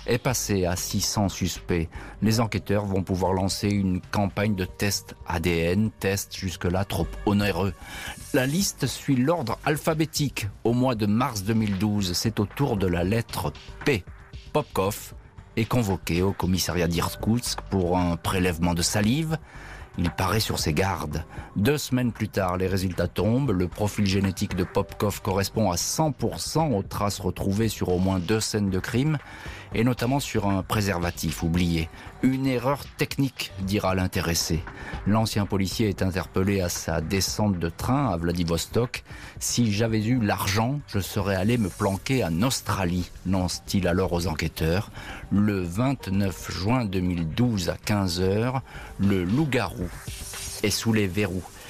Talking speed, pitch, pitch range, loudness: 145 wpm, 100 Hz, 90-115 Hz, -26 LUFS